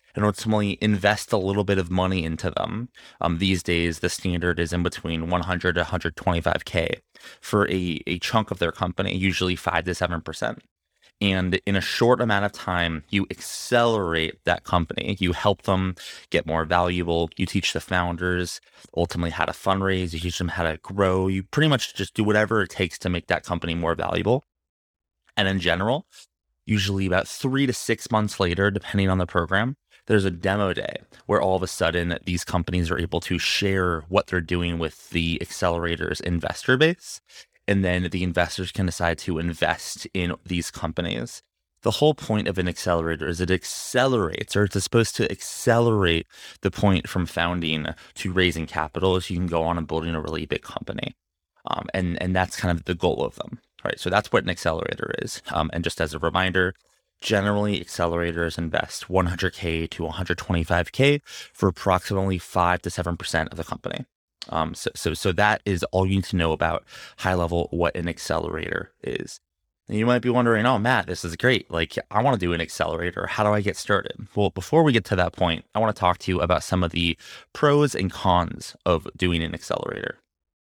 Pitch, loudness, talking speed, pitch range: 90 Hz, -24 LUFS, 195 wpm, 85-100 Hz